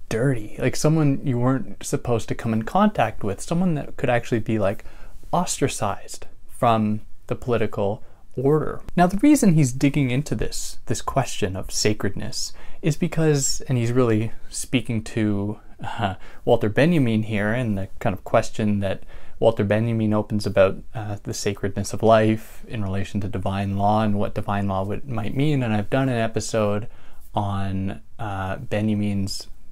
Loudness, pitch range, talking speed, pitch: -23 LUFS, 100-125 Hz, 160 wpm, 110 Hz